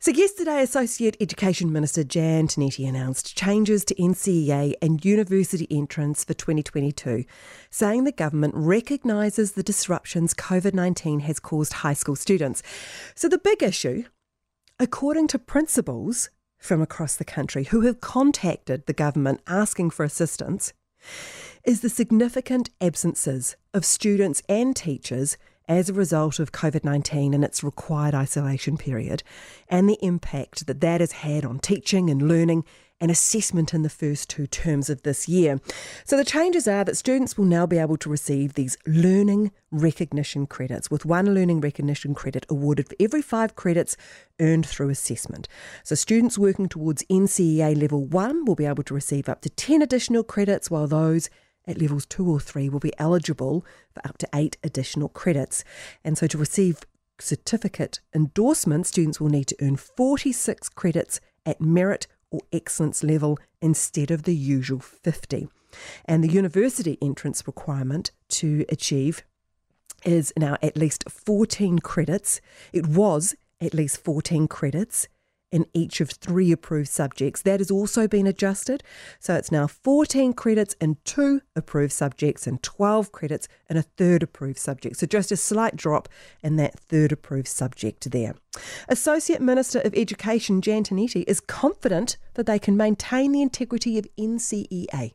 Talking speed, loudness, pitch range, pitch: 155 wpm, -23 LUFS, 145-205 Hz, 165 Hz